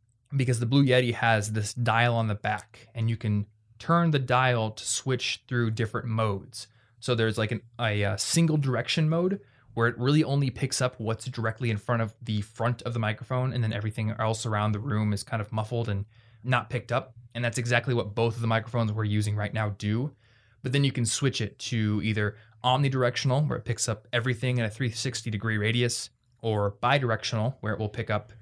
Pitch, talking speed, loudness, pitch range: 115 Hz, 210 wpm, -27 LUFS, 110-125 Hz